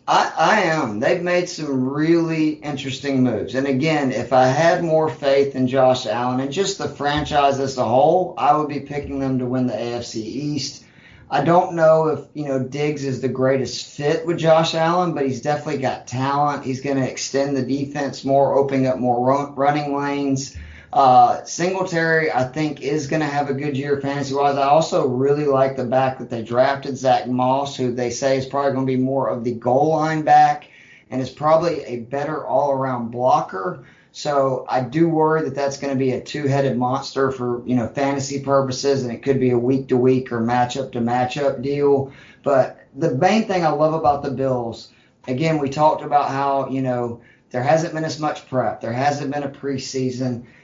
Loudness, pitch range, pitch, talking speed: -20 LUFS, 130-150 Hz, 135 Hz, 205 wpm